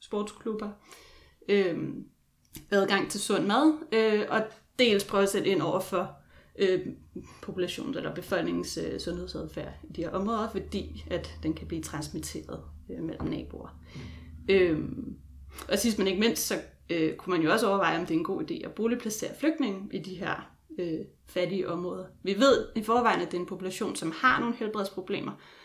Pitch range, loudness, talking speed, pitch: 170-220 Hz, -29 LUFS, 175 wpm, 195 Hz